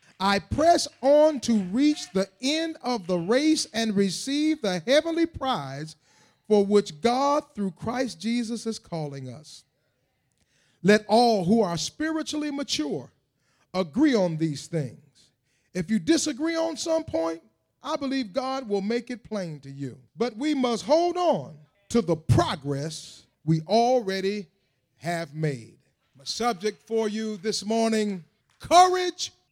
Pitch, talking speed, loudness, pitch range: 215 Hz, 140 wpm, -25 LUFS, 160-270 Hz